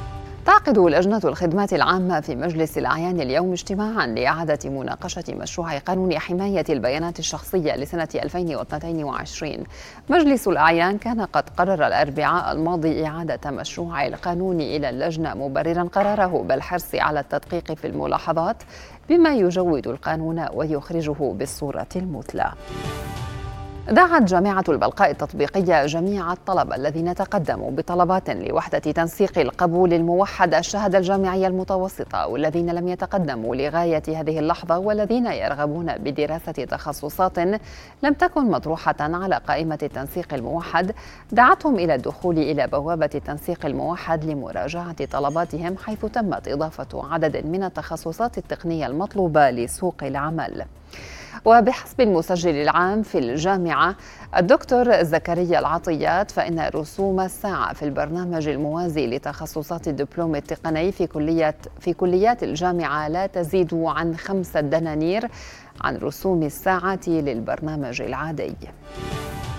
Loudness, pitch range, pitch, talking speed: -22 LUFS, 155-190 Hz, 170 Hz, 110 wpm